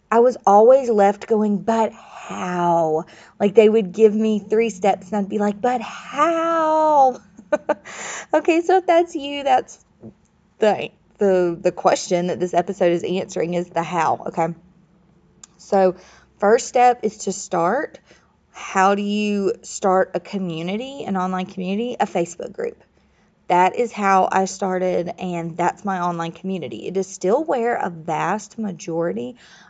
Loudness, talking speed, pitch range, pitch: -20 LUFS, 150 wpm, 180-225 Hz, 195 Hz